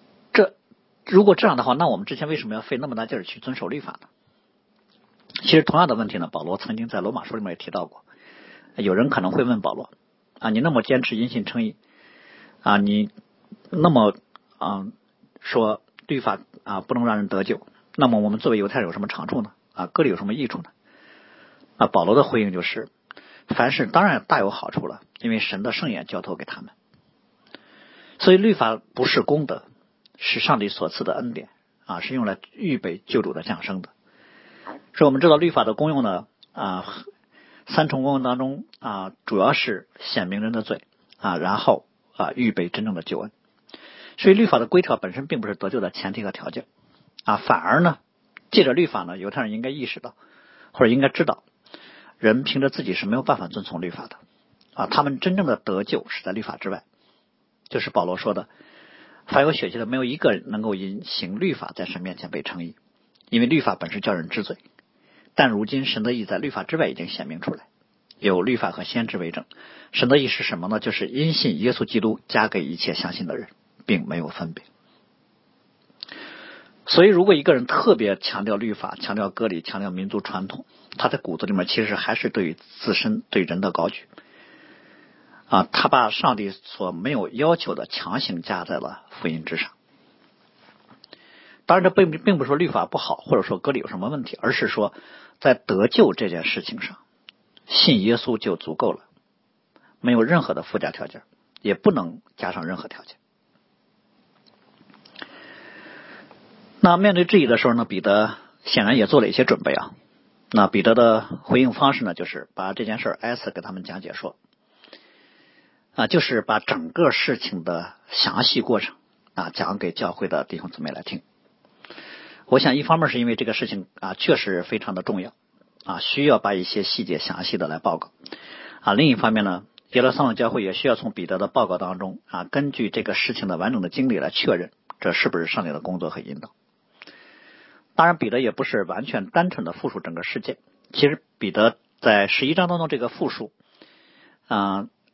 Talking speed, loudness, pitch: 280 characters per minute, -22 LUFS, 150 Hz